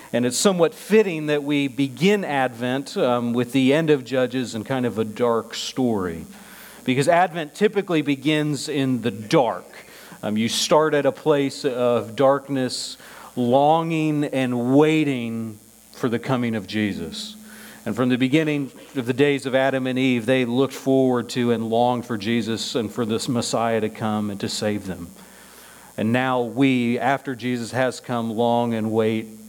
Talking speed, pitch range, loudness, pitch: 165 wpm, 120-145 Hz, -22 LUFS, 130 Hz